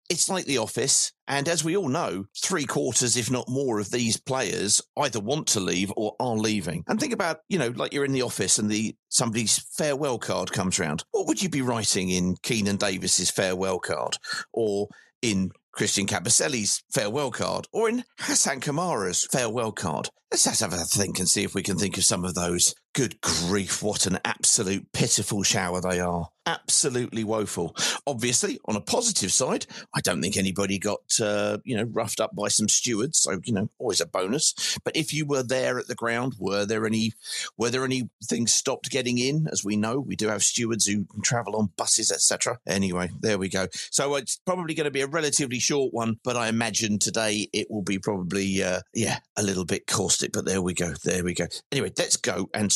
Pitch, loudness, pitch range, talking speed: 110 Hz, -25 LUFS, 95-125 Hz, 205 wpm